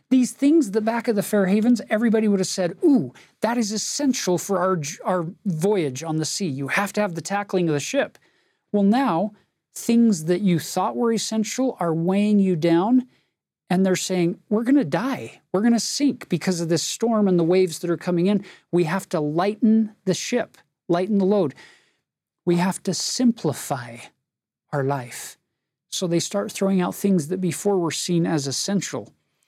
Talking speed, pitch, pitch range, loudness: 190 wpm, 190 Hz, 175-220 Hz, -22 LUFS